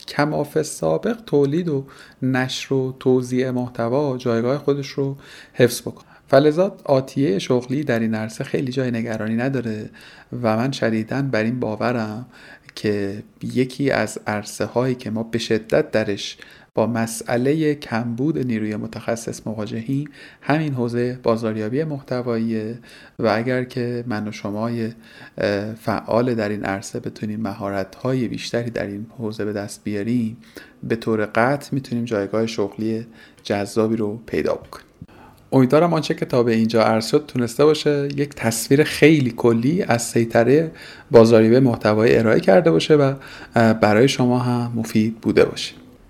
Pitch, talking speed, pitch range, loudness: 120 Hz, 135 wpm, 110-135 Hz, -20 LUFS